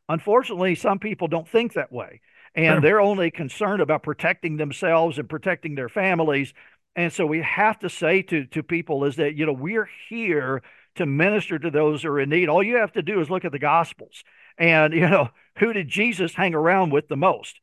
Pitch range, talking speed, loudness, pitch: 155-190 Hz, 210 wpm, -22 LUFS, 165 Hz